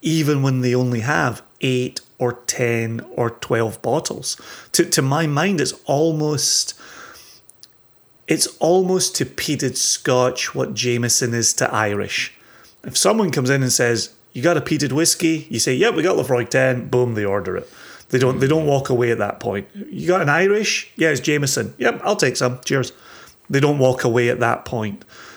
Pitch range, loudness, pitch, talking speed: 120-155 Hz, -19 LUFS, 130 Hz, 180 wpm